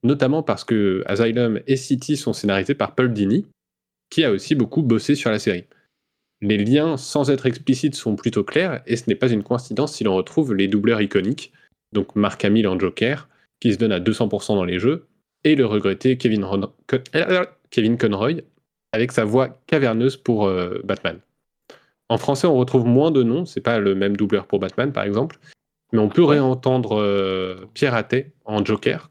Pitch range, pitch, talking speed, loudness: 105-135 Hz, 120 Hz, 195 wpm, -20 LUFS